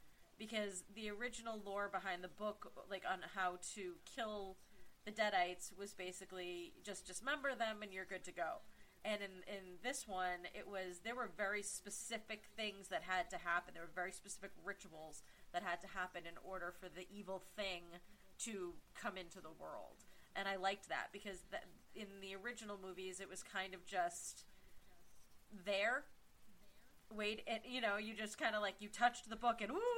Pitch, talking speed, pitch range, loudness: 195 Hz, 185 wpm, 185-215 Hz, -46 LUFS